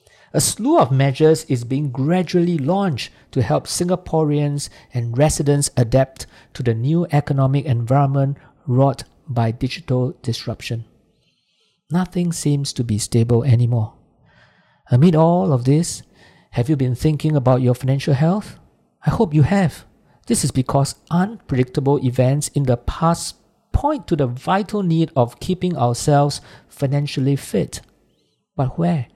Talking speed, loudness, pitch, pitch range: 135 wpm, -19 LUFS, 140 Hz, 125-165 Hz